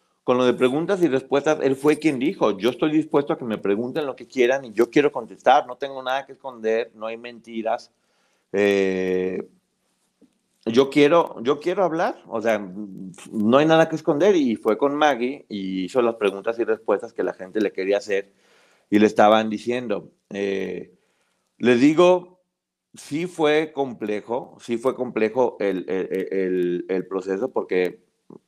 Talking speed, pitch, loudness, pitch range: 170 wpm, 120 Hz, -22 LUFS, 100-145 Hz